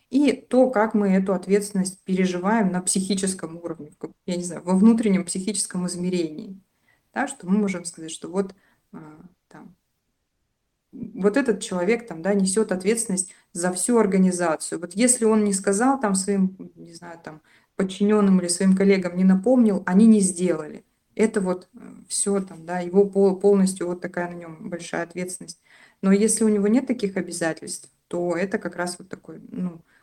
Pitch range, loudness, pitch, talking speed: 180-210 Hz, -22 LUFS, 195 Hz, 160 wpm